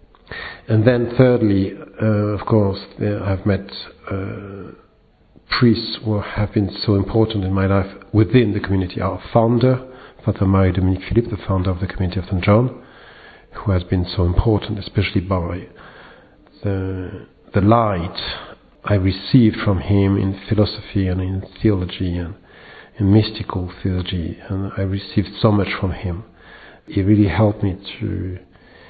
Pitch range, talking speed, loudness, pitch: 95-110 Hz, 145 wpm, -19 LUFS, 100 Hz